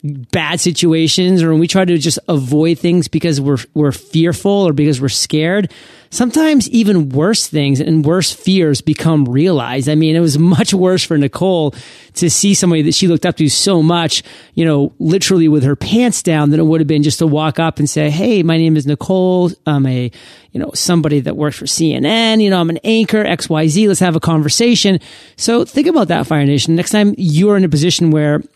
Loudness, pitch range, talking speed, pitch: -13 LUFS, 150-185 Hz, 210 wpm, 165 Hz